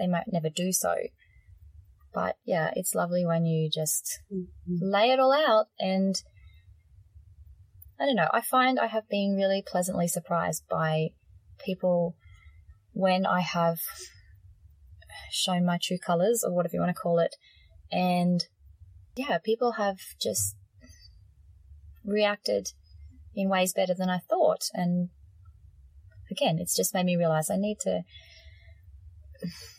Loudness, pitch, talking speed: -28 LUFS, 160 Hz, 135 wpm